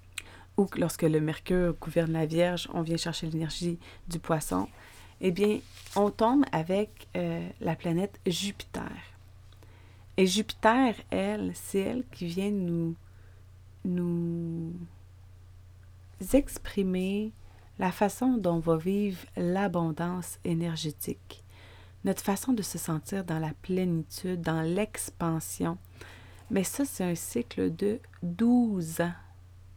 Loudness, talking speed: -30 LUFS, 115 wpm